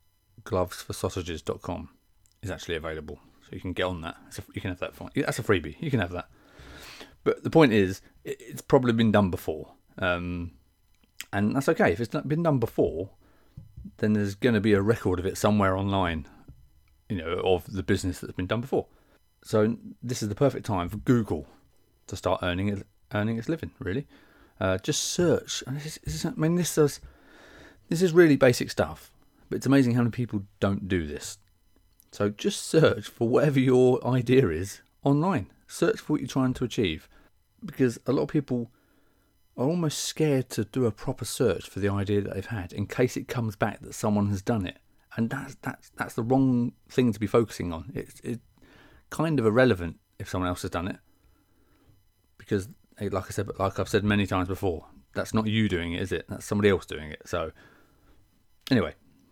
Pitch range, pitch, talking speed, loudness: 95-125 Hz, 105 Hz, 190 wpm, -27 LUFS